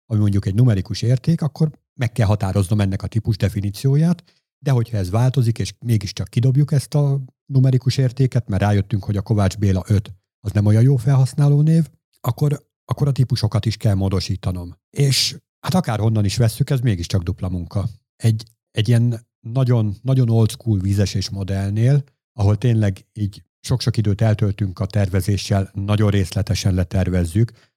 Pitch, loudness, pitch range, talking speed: 110 Hz, -19 LUFS, 100-130 Hz, 160 wpm